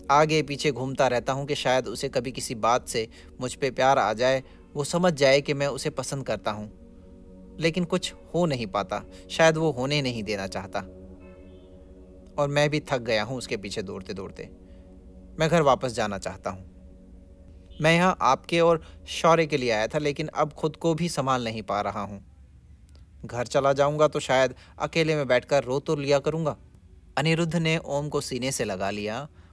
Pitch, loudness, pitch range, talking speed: 130 Hz, -25 LUFS, 95-150 Hz, 190 wpm